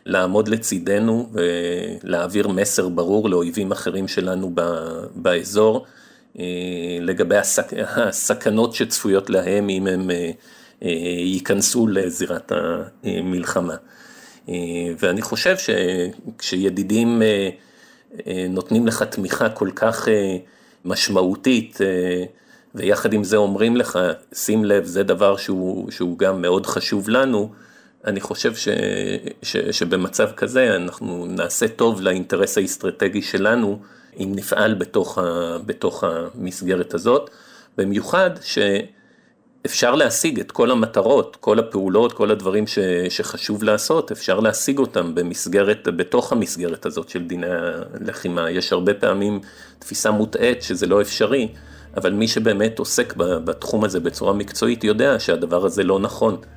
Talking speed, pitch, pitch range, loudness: 110 wpm, 95 Hz, 90-105 Hz, -20 LUFS